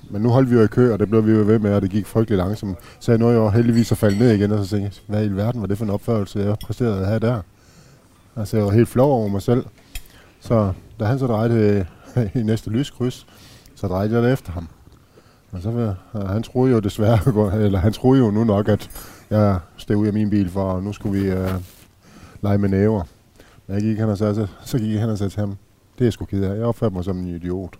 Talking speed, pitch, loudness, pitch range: 260 wpm, 105 Hz, -20 LUFS, 100-115 Hz